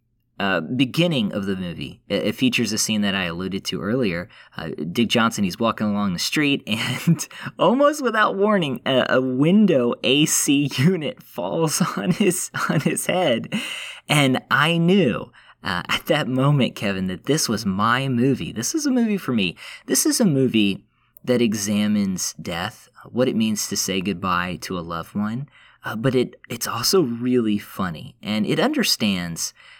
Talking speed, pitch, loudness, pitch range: 170 wpm, 125 Hz, -21 LUFS, 105-155 Hz